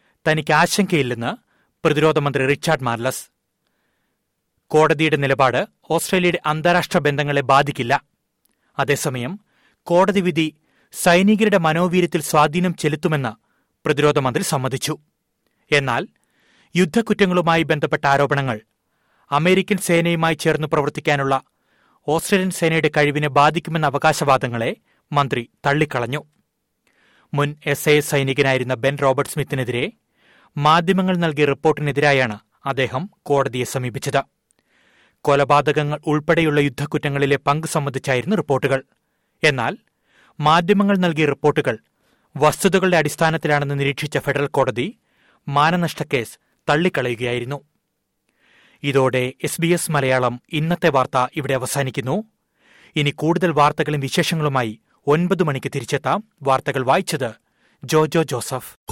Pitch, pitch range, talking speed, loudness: 150 Hz, 140-165 Hz, 90 wpm, -19 LUFS